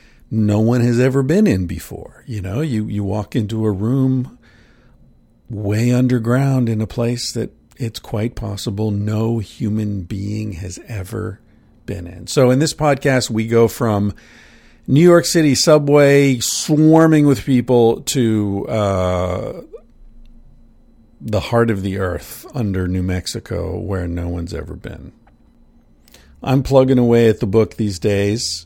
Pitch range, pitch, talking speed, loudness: 100-125 Hz, 115 Hz, 140 wpm, -17 LUFS